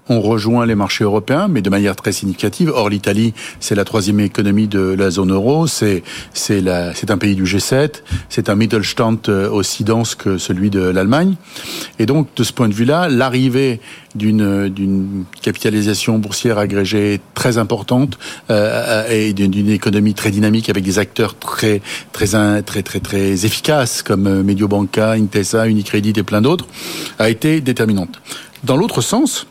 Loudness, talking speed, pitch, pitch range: -15 LUFS, 165 wpm, 105 Hz, 100-115 Hz